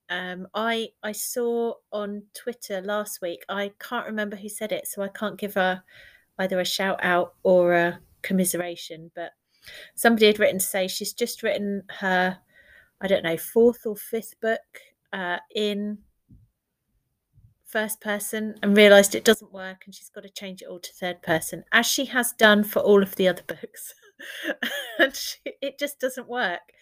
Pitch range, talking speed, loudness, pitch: 185-220 Hz, 175 wpm, -24 LUFS, 205 Hz